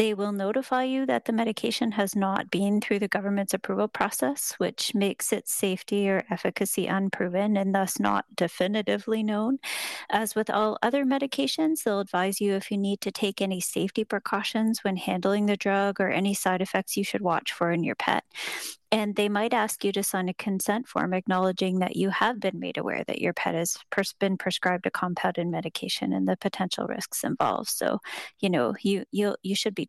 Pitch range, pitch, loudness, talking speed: 190-220 Hz, 200 Hz, -27 LUFS, 195 wpm